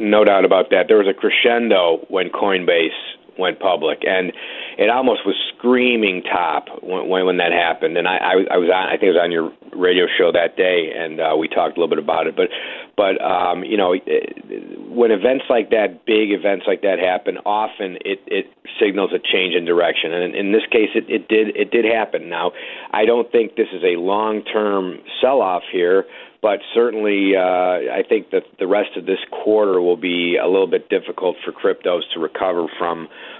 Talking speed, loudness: 205 wpm, -18 LUFS